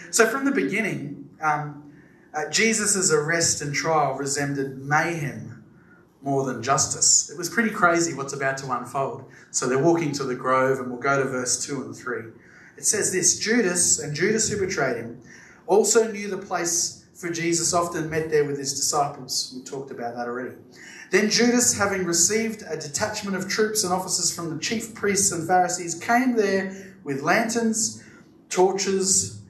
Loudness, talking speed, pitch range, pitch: -22 LUFS, 170 wpm, 140-195 Hz, 170 Hz